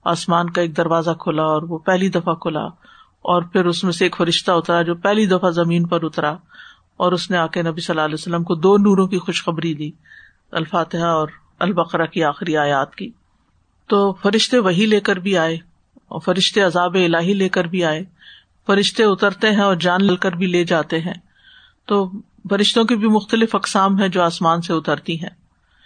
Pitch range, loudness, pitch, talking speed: 170-200 Hz, -18 LUFS, 180 Hz, 195 wpm